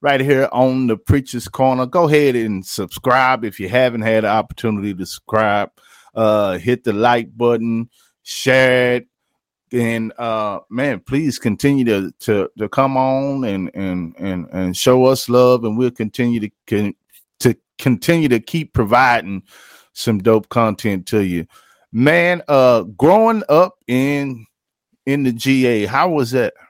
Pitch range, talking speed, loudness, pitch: 105-130 Hz, 155 wpm, -17 LUFS, 120 Hz